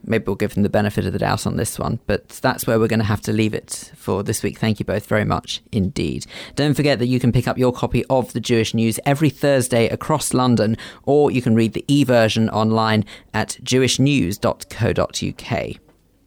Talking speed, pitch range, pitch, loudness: 210 wpm, 105-125 Hz, 115 Hz, -19 LUFS